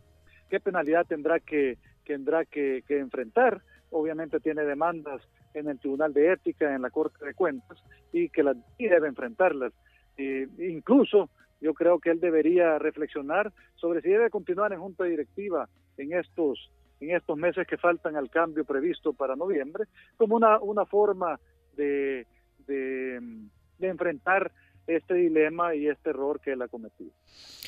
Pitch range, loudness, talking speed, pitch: 135-180 Hz, -27 LUFS, 155 wpm, 155 Hz